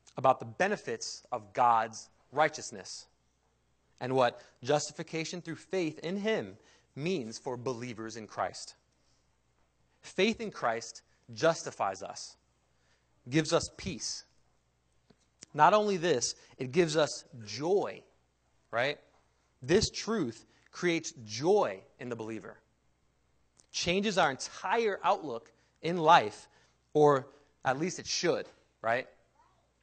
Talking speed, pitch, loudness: 105 wpm, 125 Hz, -31 LUFS